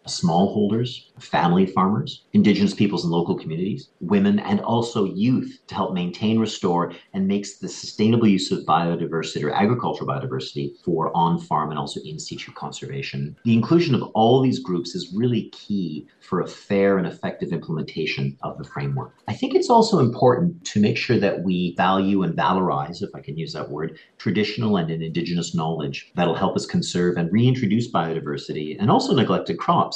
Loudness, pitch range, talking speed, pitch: -22 LUFS, 85-115 Hz, 175 wpm, 95 Hz